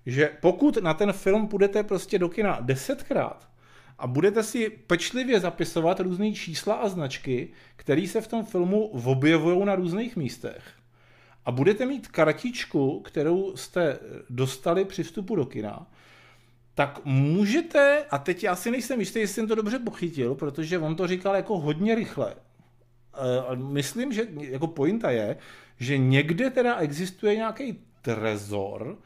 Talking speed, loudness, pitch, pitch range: 145 wpm, -26 LUFS, 175 Hz, 135-215 Hz